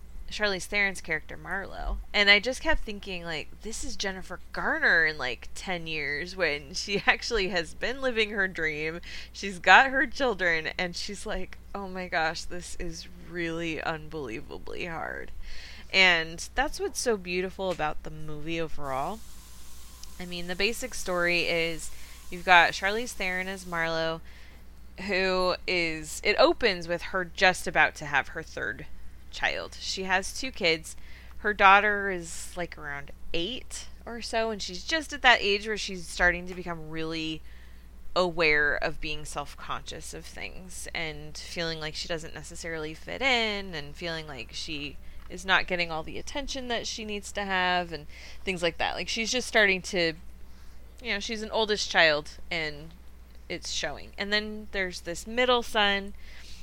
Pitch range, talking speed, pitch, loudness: 155-200 Hz, 160 wpm, 180 Hz, -27 LUFS